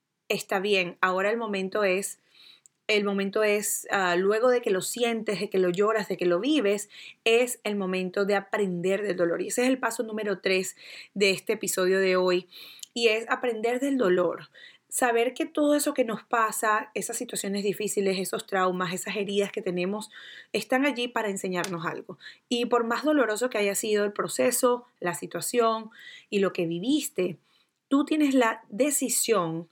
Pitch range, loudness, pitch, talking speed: 190-240 Hz, -26 LUFS, 210 Hz, 175 wpm